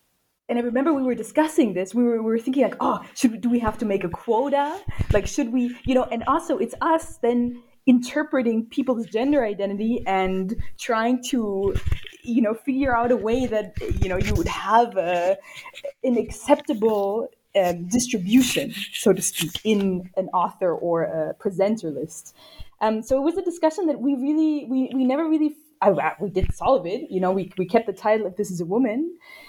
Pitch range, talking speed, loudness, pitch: 205-275 Hz, 195 wpm, -23 LUFS, 235 Hz